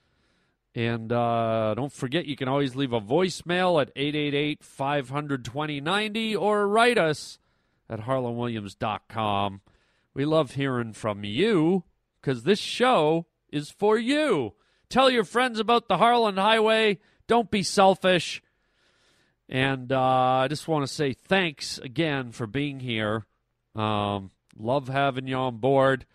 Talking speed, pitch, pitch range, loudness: 130 wpm, 140 Hz, 120-185 Hz, -25 LUFS